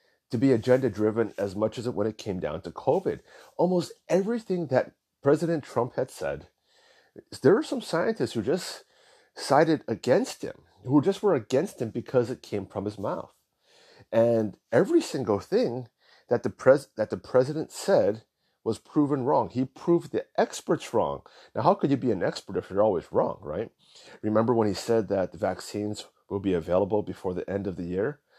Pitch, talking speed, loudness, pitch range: 125 Hz, 185 wpm, -27 LUFS, 110-150 Hz